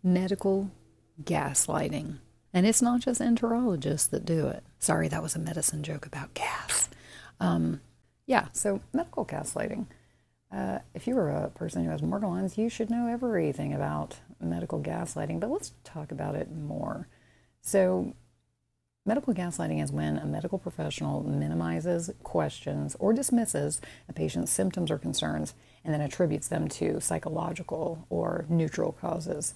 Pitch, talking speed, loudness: 155 Hz, 145 wpm, -30 LUFS